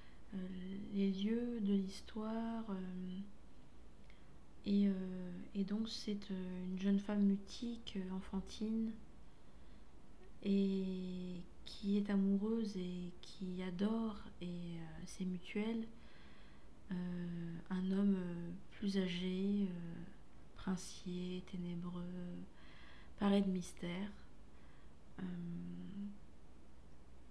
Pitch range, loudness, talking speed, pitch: 175-200 Hz, -42 LUFS, 80 wpm, 185 Hz